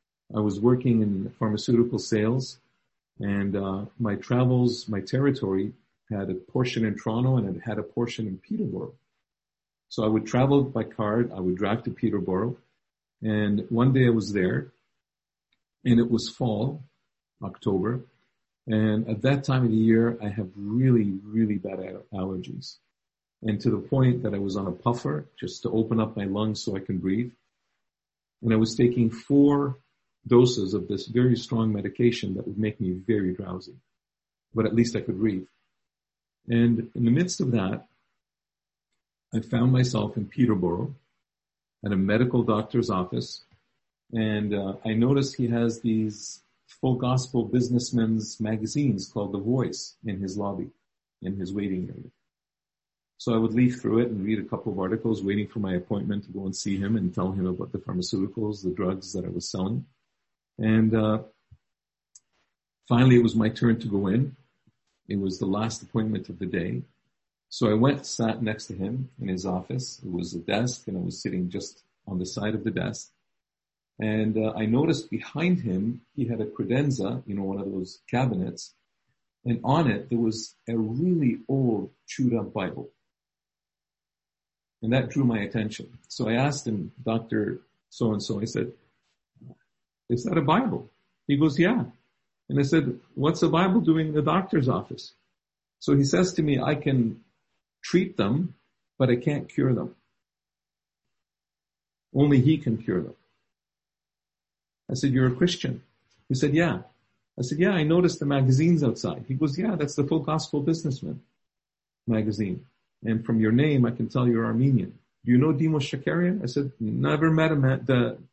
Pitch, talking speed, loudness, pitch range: 115 Hz, 175 wpm, -26 LUFS, 100-125 Hz